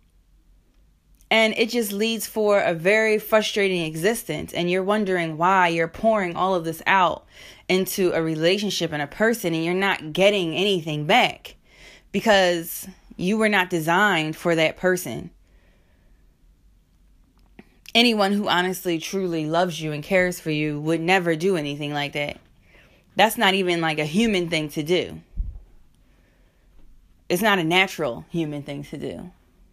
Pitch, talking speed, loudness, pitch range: 175 Hz, 145 wpm, -21 LUFS, 150-195 Hz